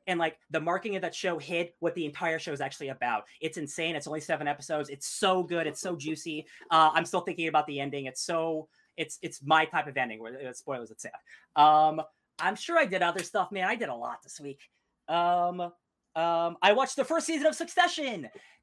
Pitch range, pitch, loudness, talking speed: 150-175 Hz, 160 Hz, -29 LUFS, 220 wpm